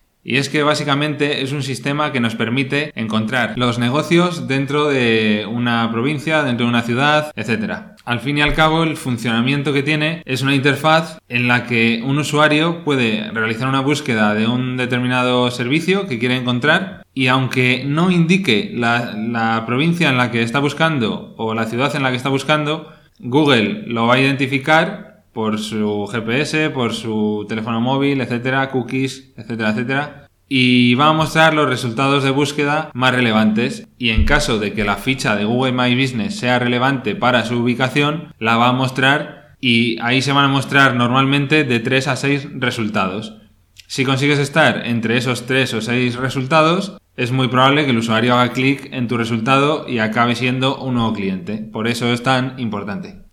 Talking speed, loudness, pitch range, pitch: 180 wpm, -17 LUFS, 115-145 Hz, 130 Hz